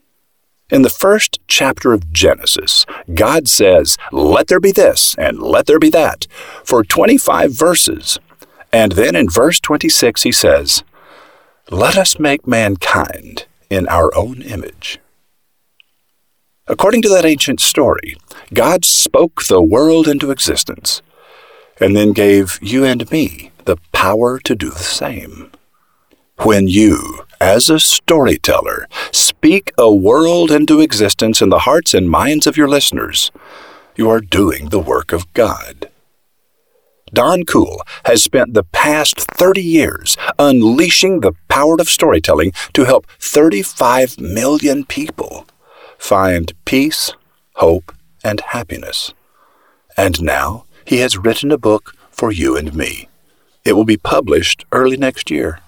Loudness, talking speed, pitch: -12 LUFS, 135 wpm, 145 Hz